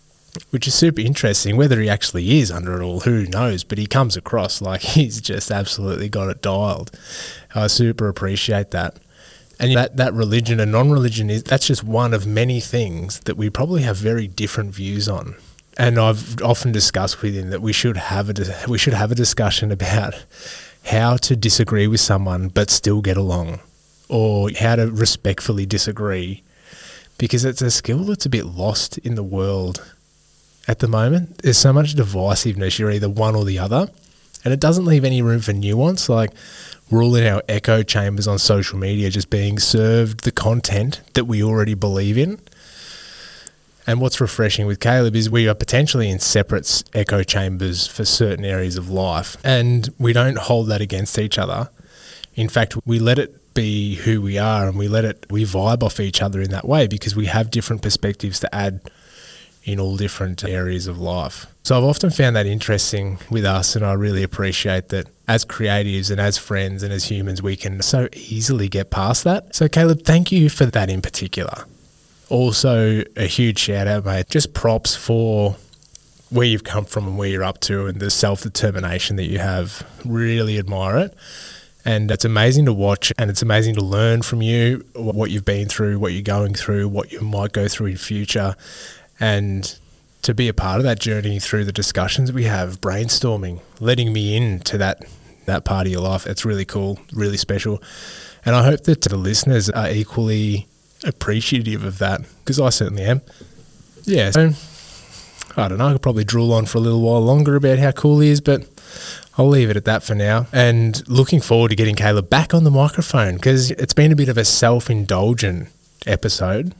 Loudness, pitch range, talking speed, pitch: -18 LUFS, 100-120 Hz, 190 wpm, 110 Hz